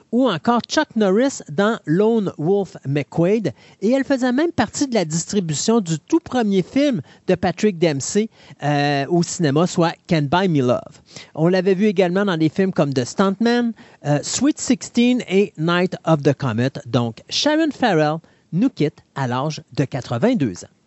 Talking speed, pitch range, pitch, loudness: 170 wpm, 150-225 Hz, 180 Hz, -19 LUFS